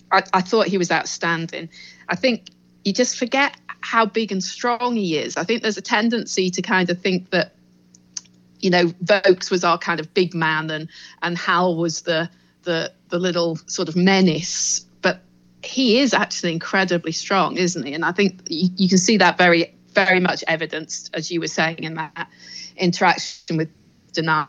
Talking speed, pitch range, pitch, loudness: 185 wpm, 160-195 Hz, 175 Hz, -20 LUFS